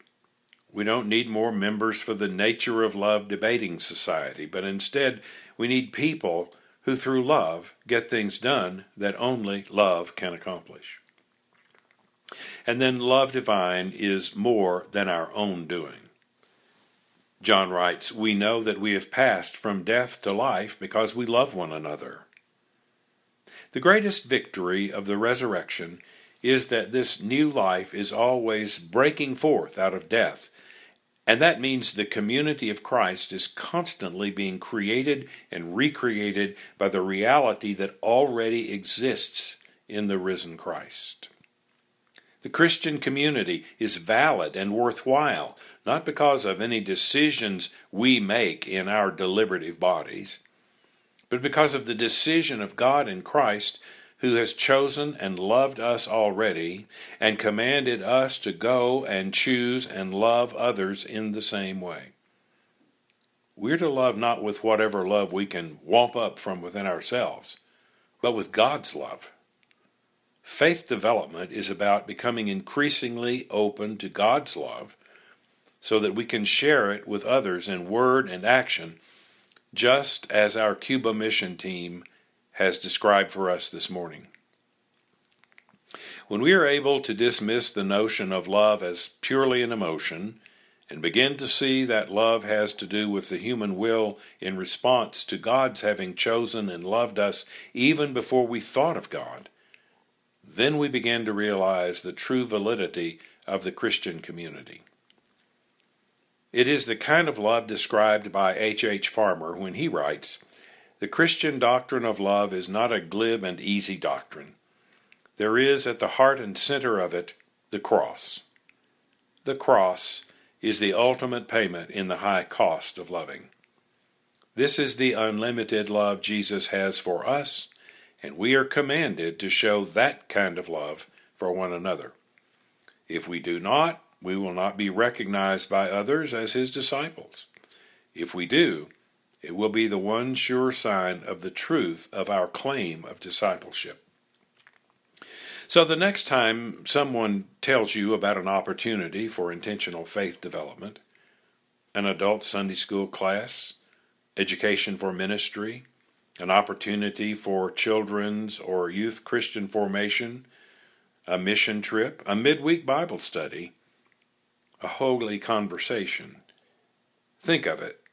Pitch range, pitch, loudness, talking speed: 95-125 Hz, 110 Hz, -25 LUFS, 140 wpm